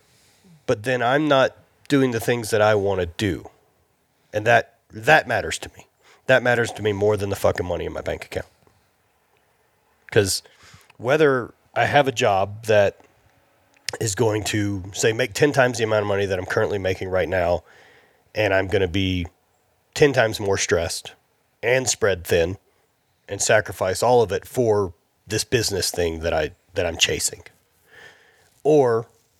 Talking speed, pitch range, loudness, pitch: 165 wpm, 100-120 Hz, -21 LUFS, 105 Hz